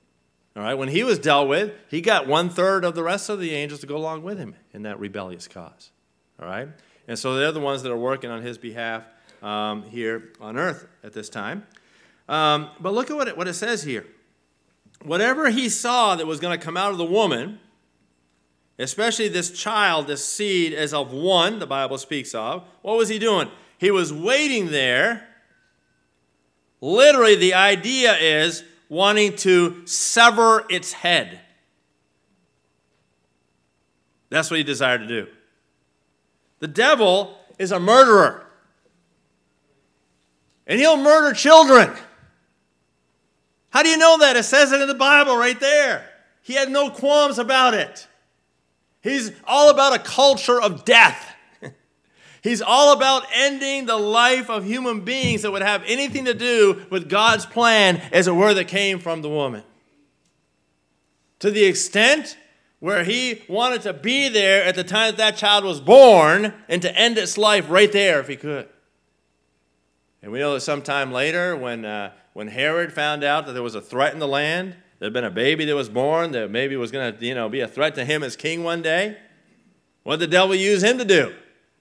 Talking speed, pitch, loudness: 180 wpm, 170 Hz, -18 LUFS